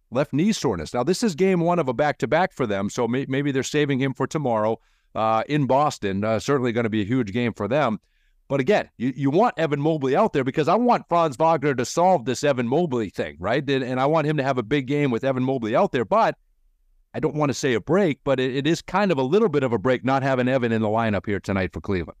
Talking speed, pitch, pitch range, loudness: 275 wpm, 135 Hz, 115-150 Hz, -22 LUFS